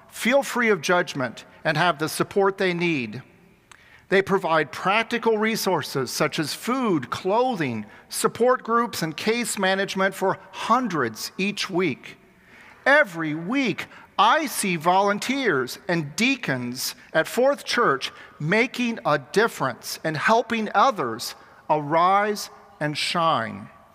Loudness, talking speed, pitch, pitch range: -23 LUFS, 115 wpm, 195 Hz, 160-230 Hz